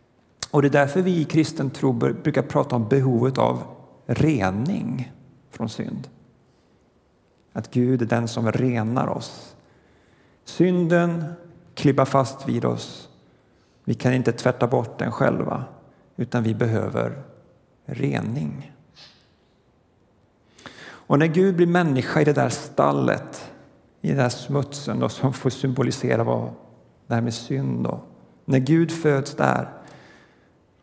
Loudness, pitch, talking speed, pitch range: -23 LUFS, 130 Hz, 125 wpm, 115-145 Hz